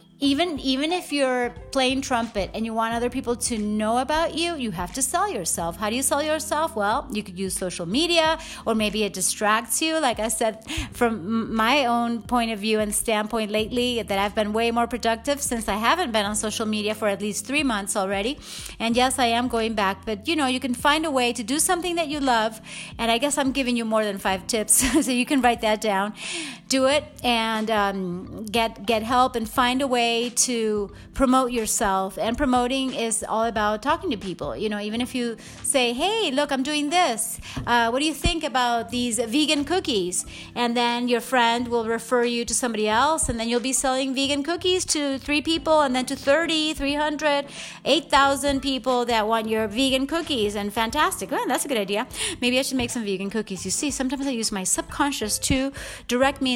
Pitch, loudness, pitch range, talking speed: 245 Hz, -23 LUFS, 220-280 Hz, 215 wpm